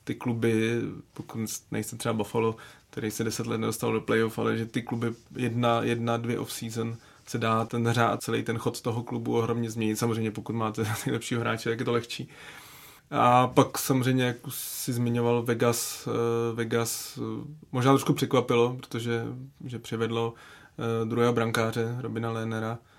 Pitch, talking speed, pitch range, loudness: 115 Hz, 155 wpm, 115-125 Hz, -28 LUFS